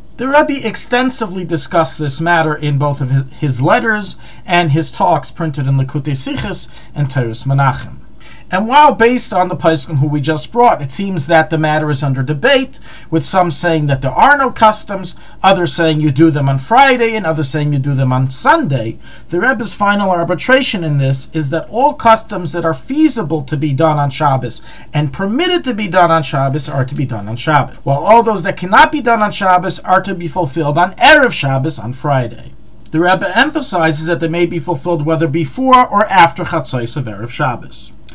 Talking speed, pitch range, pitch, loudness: 200 wpm, 145-200 Hz, 165 Hz, -13 LUFS